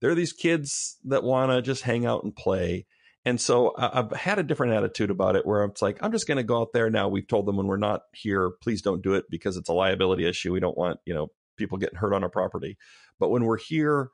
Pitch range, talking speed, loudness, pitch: 95-130 Hz, 265 wpm, -26 LUFS, 115 Hz